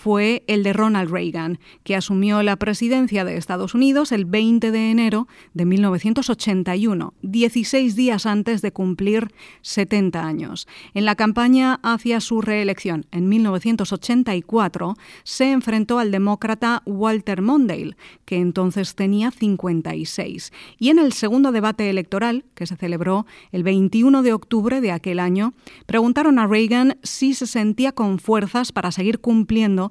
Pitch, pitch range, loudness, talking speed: 215 Hz, 195-235 Hz, -19 LUFS, 140 wpm